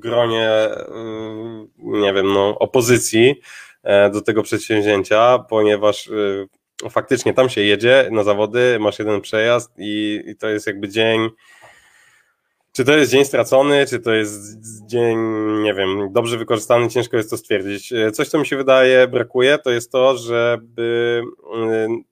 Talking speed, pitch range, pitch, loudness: 135 wpm, 105-120 Hz, 115 Hz, -17 LUFS